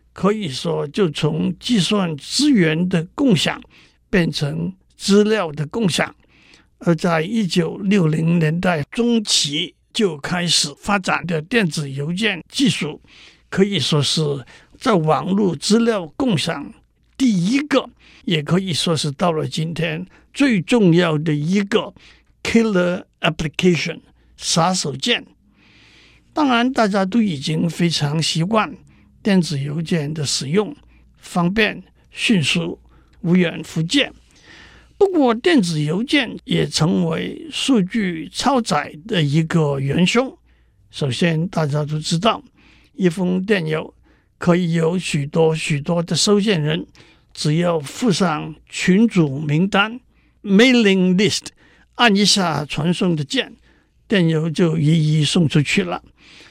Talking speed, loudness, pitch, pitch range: 205 characters per minute, -18 LUFS, 175 Hz, 160-210 Hz